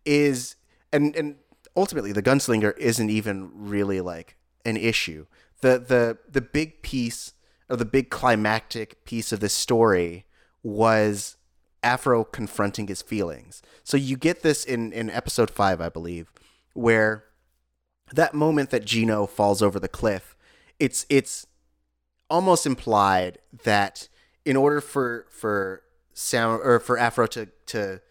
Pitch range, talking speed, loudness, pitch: 100-130 Hz, 135 wpm, -24 LUFS, 115 Hz